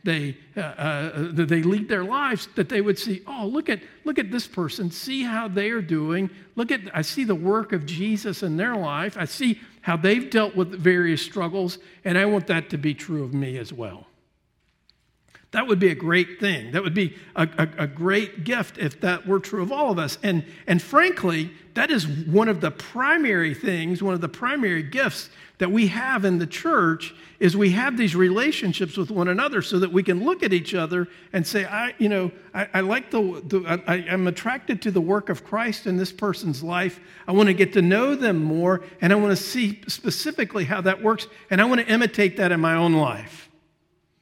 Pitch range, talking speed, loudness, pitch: 175-210 Hz, 215 wpm, -23 LUFS, 190 Hz